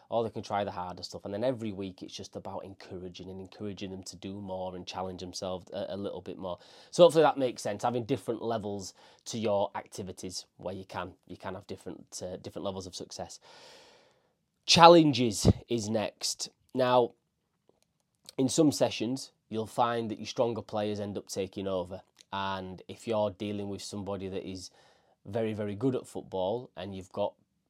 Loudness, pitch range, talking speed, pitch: -30 LUFS, 95-120 Hz, 185 wpm, 100 Hz